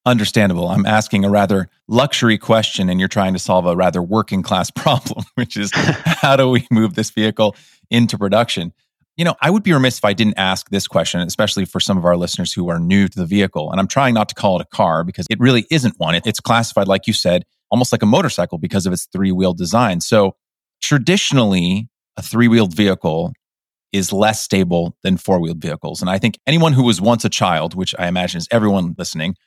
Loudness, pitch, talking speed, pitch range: -16 LUFS, 105 Hz, 220 wpm, 95-120 Hz